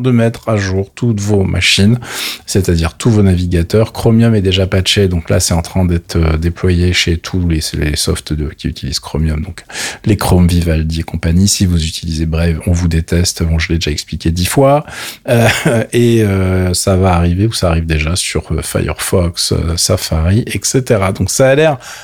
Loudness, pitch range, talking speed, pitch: -13 LUFS, 85-105 Hz, 190 wpm, 90 Hz